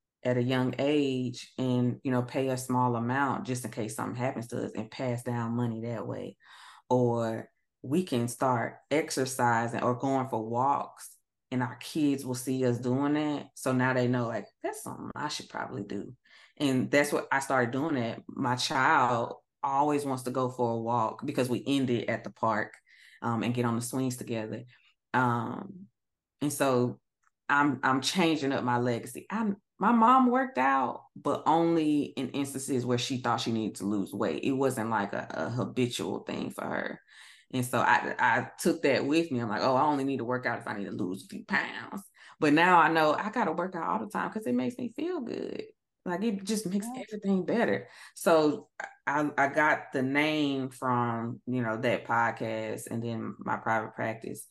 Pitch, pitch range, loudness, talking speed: 130 Hz, 120-145 Hz, -29 LUFS, 200 wpm